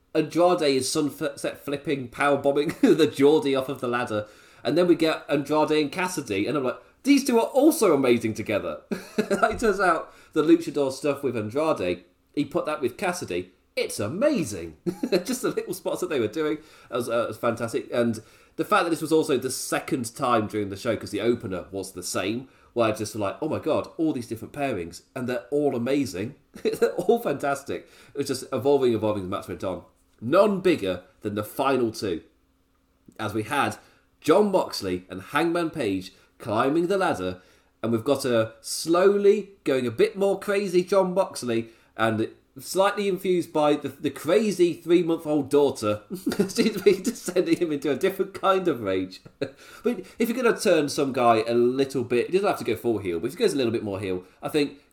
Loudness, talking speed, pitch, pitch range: -25 LUFS, 200 wpm, 145 Hz, 115-175 Hz